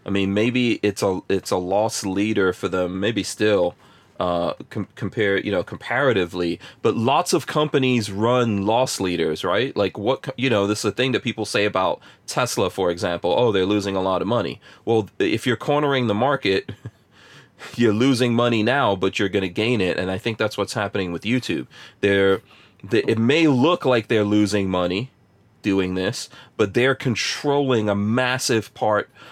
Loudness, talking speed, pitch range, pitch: -21 LUFS, 180 wpm, 100-125 Hz, 105 Hz